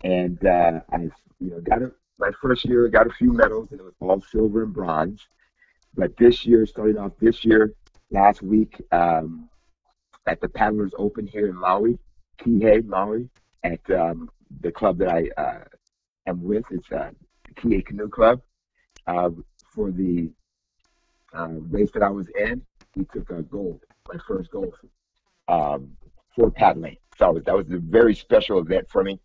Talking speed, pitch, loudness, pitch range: 175 wpm, 100 Hz, -22 LUFS, 90-115 Hz